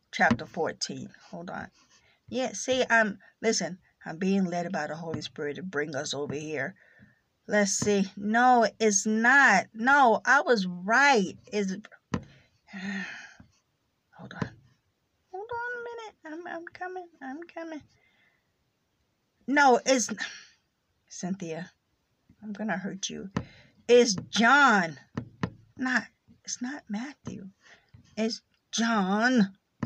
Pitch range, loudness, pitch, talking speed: 195-265 Hz, -26 LUFS, 220 Hz, 115 wpm